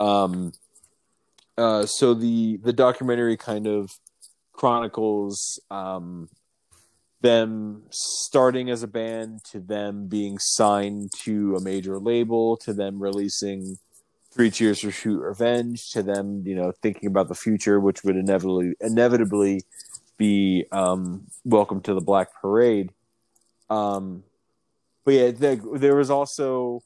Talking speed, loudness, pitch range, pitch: 125 wpm, -23 LUFS, 100-115 Hz, 105 Hz